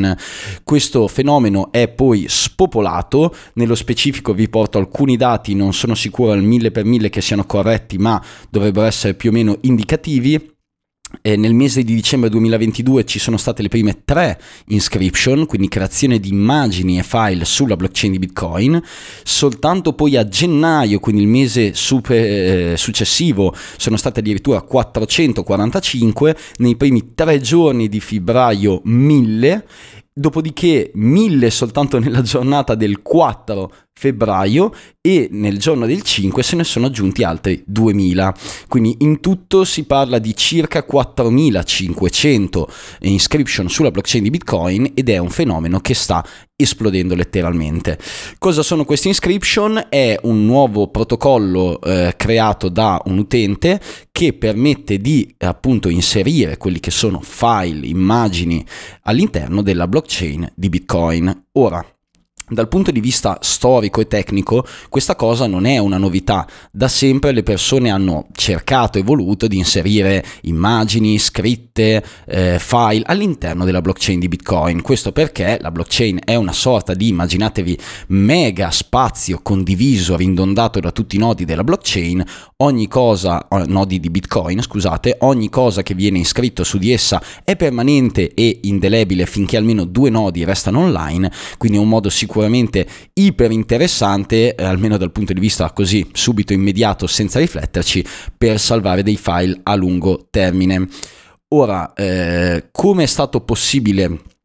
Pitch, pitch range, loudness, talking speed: 110 Hz, 95-125 Hz, -15 LUFS, 140 wpm